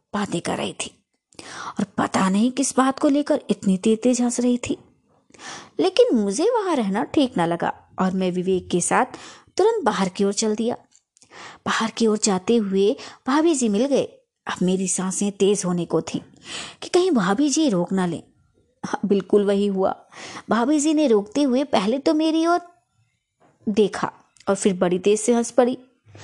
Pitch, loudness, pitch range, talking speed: 220 Hz, -21 LUFS, 195-280 Hz, 180 wpm